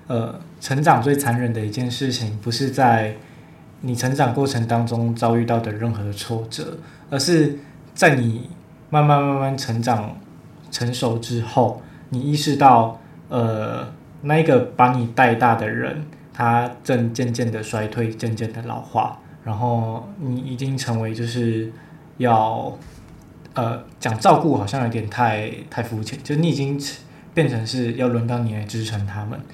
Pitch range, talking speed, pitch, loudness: 115-140 Hz, 220 characters per minute, 120 Hz, -21 LUFS